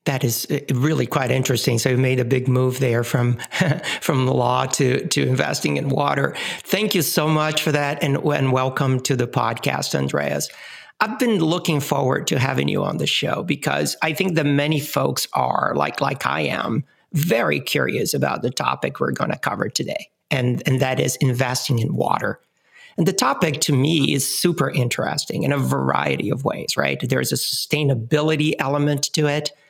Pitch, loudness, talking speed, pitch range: 140 Hz, -20 LUFS, 190 wpm, 130-150 Hz